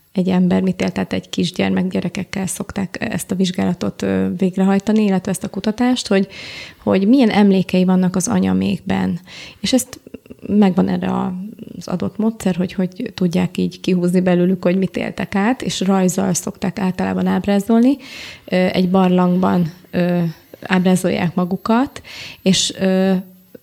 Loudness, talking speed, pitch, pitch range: -18 LUFS, 125 wpm, 185 Hz, 180-200 Hz